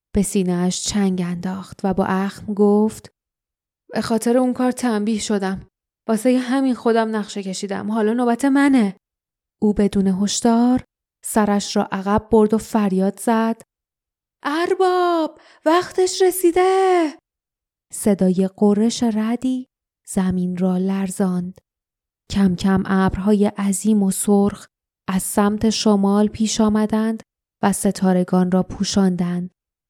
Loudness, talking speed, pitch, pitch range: -19 LUFS, 110 wpm, 210 Hz, 195-235 Hz